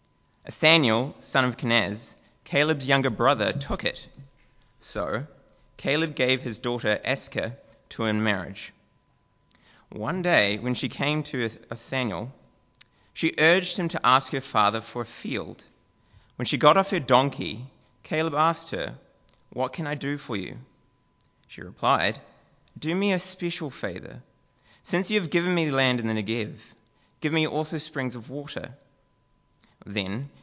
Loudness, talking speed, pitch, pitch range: -25 LUFS, 150 wpm, 135 Hz, 115-160 Hz